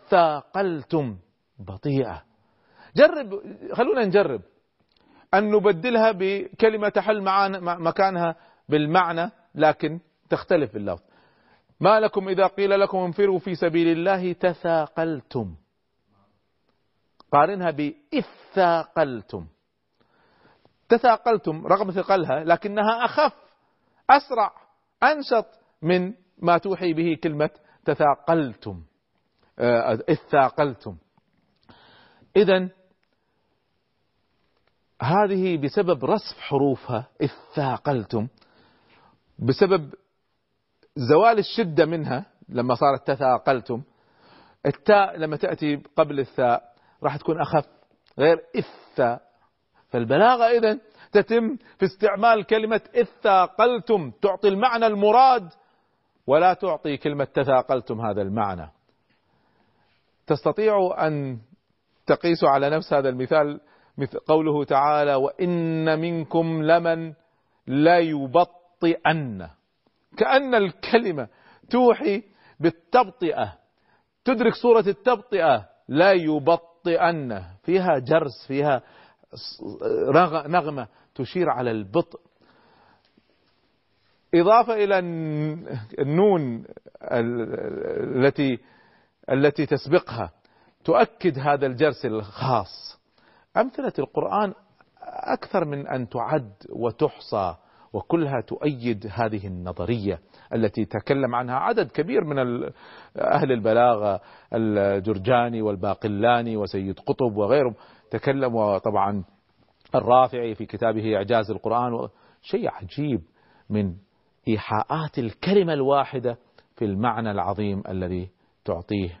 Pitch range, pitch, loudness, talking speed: 120-190 Hz, 155 Hz, -23 LUFS, 80 wpm